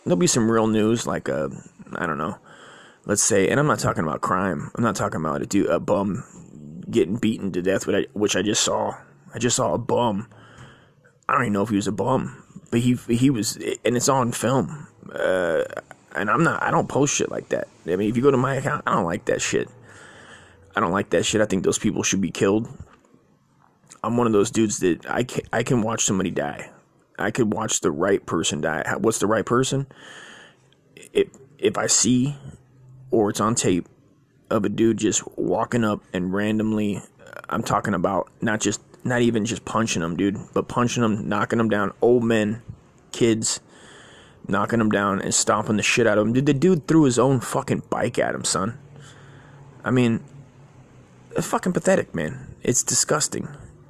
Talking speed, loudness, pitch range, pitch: 200 wpm, -22 LUFS, 105-130 Hz, 115 Hz